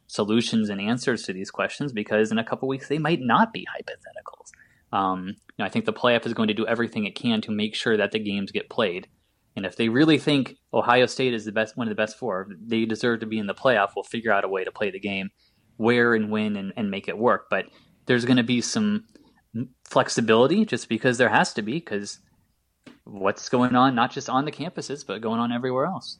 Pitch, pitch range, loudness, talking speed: 120 Hz, 110-135 Hz, -24 LUFS, 240 wpm